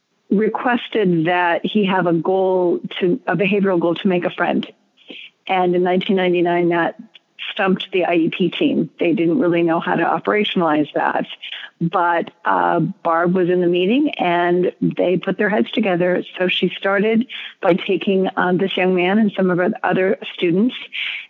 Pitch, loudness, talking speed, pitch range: 185 Hz, -18 LUFS, 165 wpm, 175-200 Hz